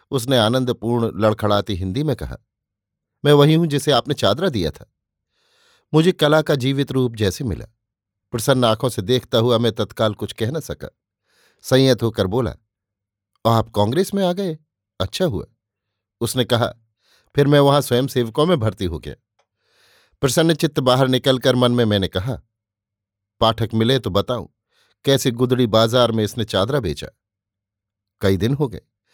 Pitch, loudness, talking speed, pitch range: 115 Hz, -19 LUFS, 155 wpm, 105-135 Hz